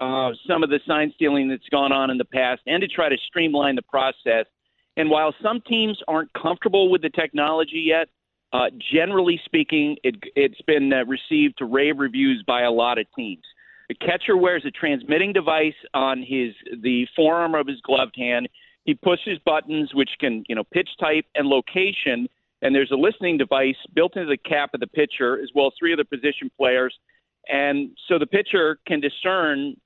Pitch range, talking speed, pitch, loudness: 135-190 Hz, 195 wpm, 155 Hz, -21 LUFS